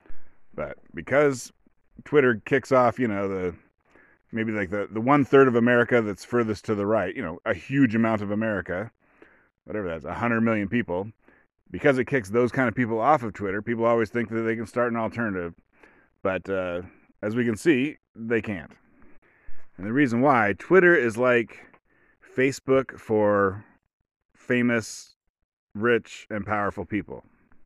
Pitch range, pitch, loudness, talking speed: 105-125 Hz, 115 Hz, -24 LUFS, 160 wpm